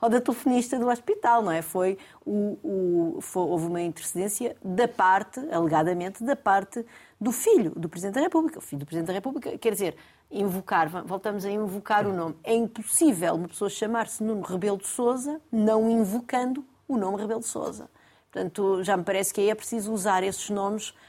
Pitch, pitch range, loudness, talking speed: 205 Hz, 190-235 Hz, -26 LUFS, 190 wpm